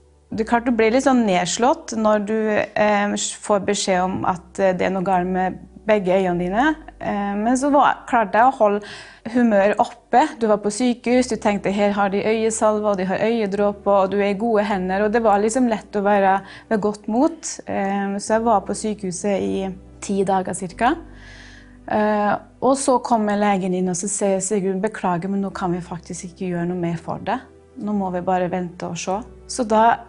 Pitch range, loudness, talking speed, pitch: 190-225 Hz, -20 LUFS, 210 wpm, 205 Hz